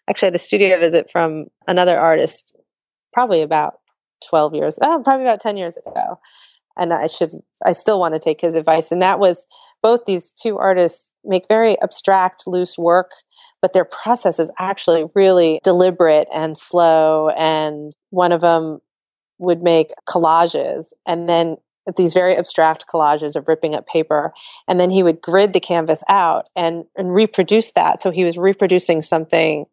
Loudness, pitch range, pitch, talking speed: -16 LUFS, 160-190 Hz, 175 Hz, 165 wpm